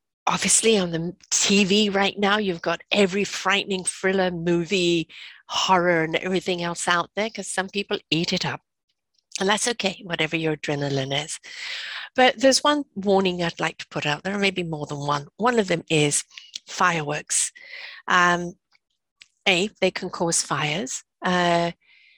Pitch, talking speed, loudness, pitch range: 185 Hz, 155 wpm, -22 LUFS, 170-205 Hz